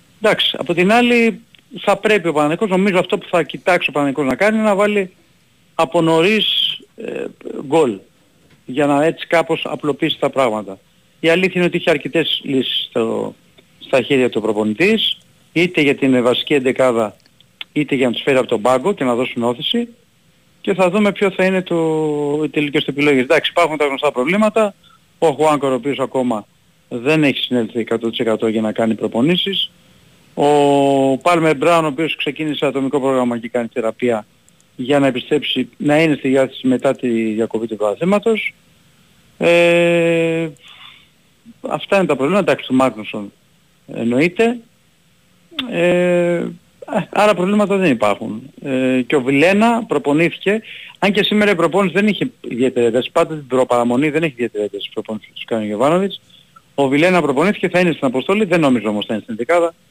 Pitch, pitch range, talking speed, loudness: 155 Hz, 130-180 Hz, 165 wpm, -16 LUFS